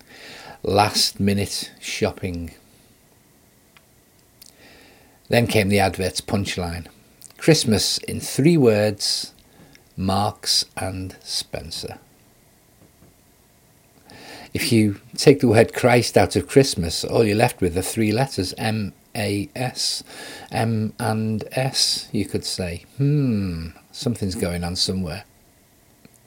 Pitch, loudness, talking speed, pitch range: 105 Hz, -21 LUFS, 105 wpm, 95-120 Hz